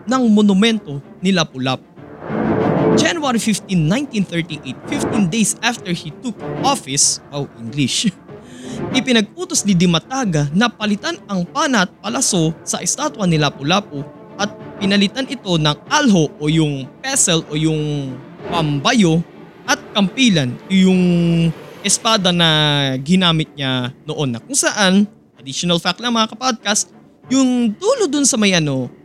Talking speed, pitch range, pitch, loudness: 125 wpm, 155-225 Hz, 185 Hz, -16 LUFS